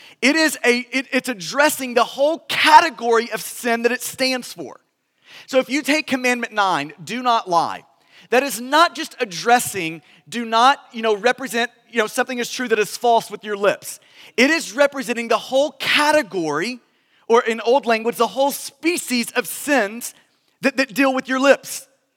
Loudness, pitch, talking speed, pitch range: -19 LUFS, 250 Hz, 180 wpm, 230-270 Hz